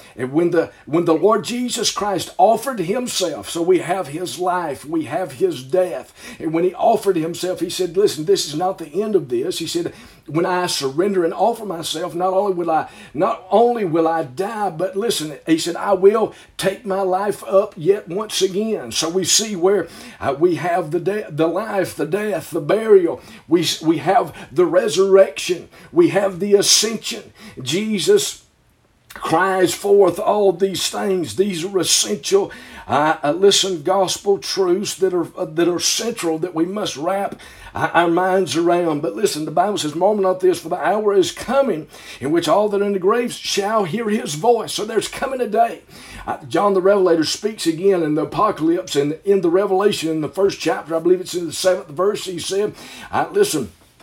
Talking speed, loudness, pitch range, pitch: 190 wpm, -18 LUFS, 170-210 Hz, 190 Hz